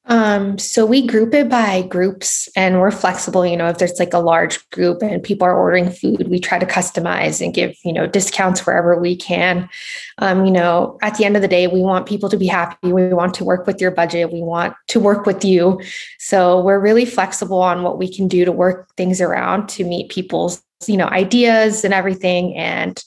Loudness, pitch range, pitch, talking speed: -16 LUFS, 180-200 Hz, 185 Hz, 220 wpm